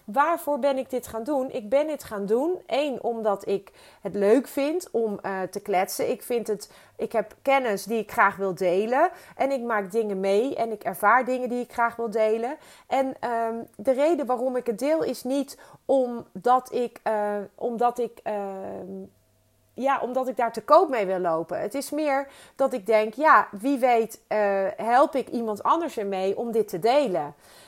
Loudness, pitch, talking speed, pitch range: -25 LUFS, 235 Hz, 195 wpm, 205-270 Hz